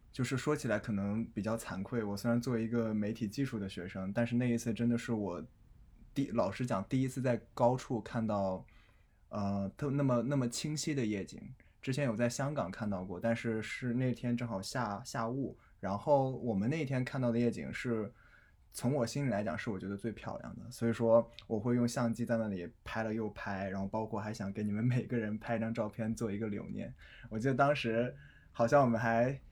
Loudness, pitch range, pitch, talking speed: -35 LUFS, 105-125 Hz, 115 Hz, 300 characters per minute